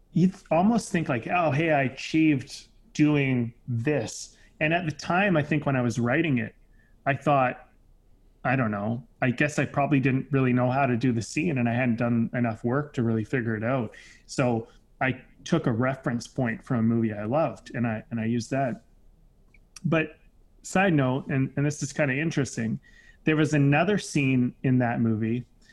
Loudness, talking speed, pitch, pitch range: -26 LUFS, 195 wpm, 130 Hz, 115-150 Hz